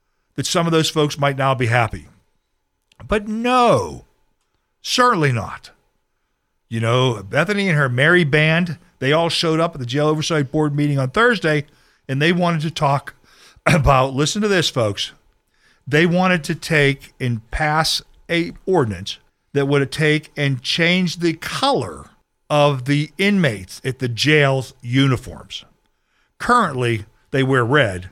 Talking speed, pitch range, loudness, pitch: 145 wpm, 130-165 Hz, -18 LUFS, 150 Hz